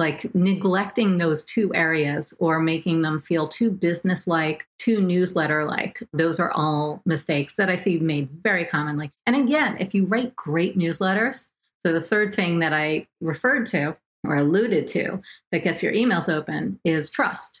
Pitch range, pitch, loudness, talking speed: 155-200 Hz, 170 Hz, -23 LUFS, 170 wpm